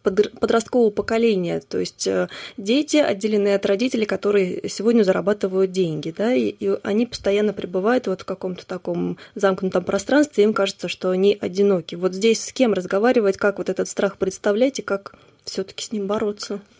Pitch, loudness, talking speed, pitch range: 200 Hz, -21 LUFS, 170 wpm, 190-220 Hz